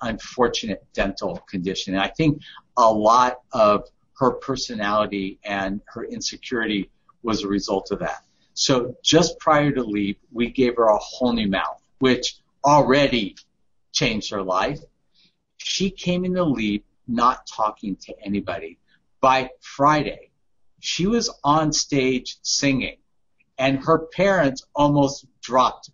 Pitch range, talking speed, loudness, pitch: 105-150 Hz, 130 wpm, -22 LUFS, 130 Hz